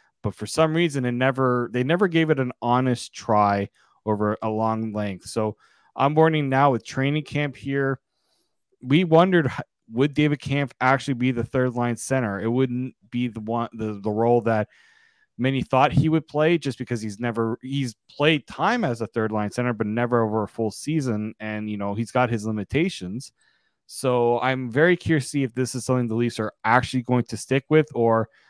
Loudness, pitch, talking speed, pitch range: -23 LUFS, 125 Hz, 200 wpm, 115-140 Hz